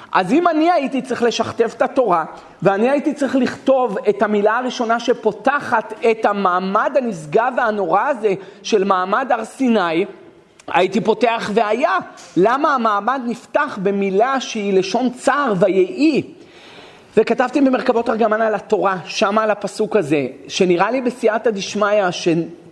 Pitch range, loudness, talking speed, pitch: 200-255 Hz, -17 LUFS, 130 wpm, 225 Hz